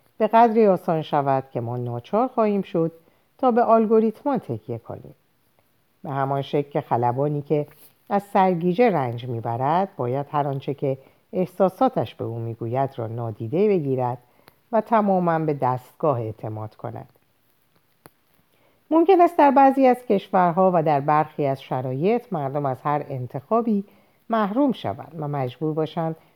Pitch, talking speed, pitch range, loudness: 155 Hz, 140 wpm, 130-205 Hz, -22 LUFS